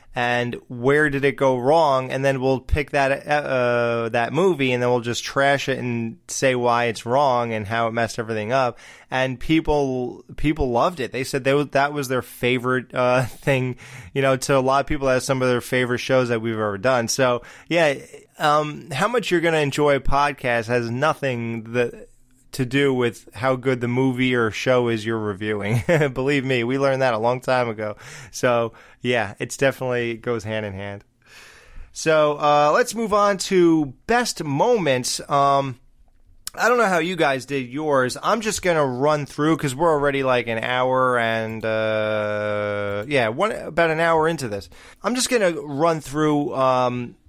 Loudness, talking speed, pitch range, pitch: -21 LUFS, 190 wpm, 120-145 Hz, 130 Hz